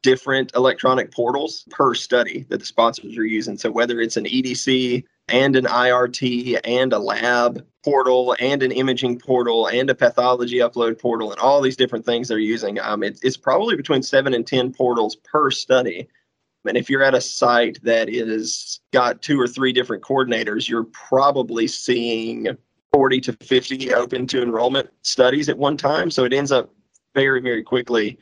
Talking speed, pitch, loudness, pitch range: 175 wpm, 125 Hz, -19 LUFS, 115-130 Hz